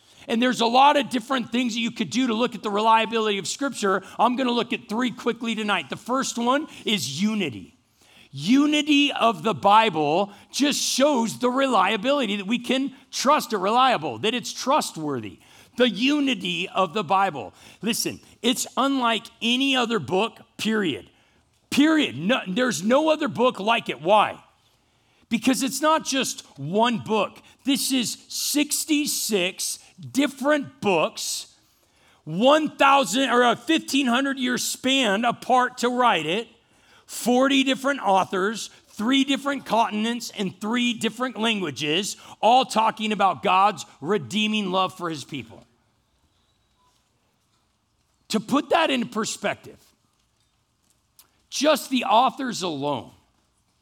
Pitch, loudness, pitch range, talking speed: 230 Hz, -22 LUFS, 195-265 Hz, 130 wpm